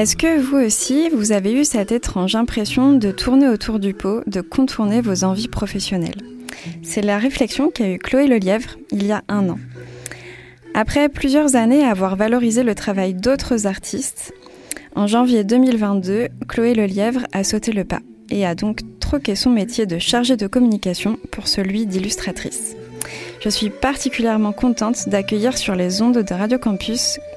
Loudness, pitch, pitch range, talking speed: -18 LUFS, 215 Hz, 195-250 Hz, 165 wpm